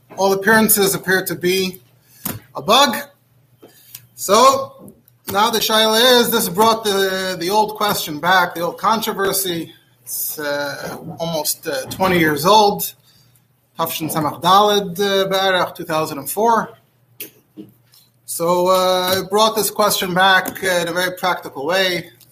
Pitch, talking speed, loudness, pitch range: 185 Hz, 135 wpm, -16 LUFS, 150-205 Hz